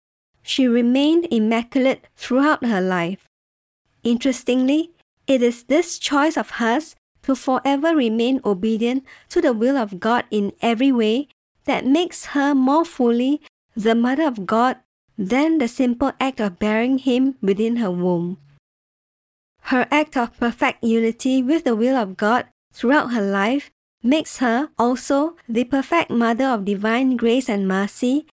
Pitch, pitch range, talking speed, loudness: 250 Hz, 230-275 Hz, 145 wpm, -20 LUFS